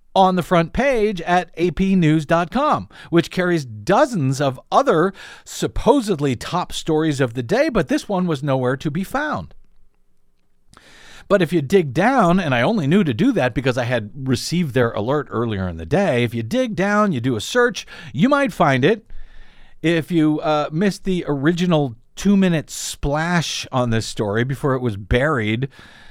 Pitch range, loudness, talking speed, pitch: 130-185 Hz, -19 LUFS, 170 wpm, 155 Hz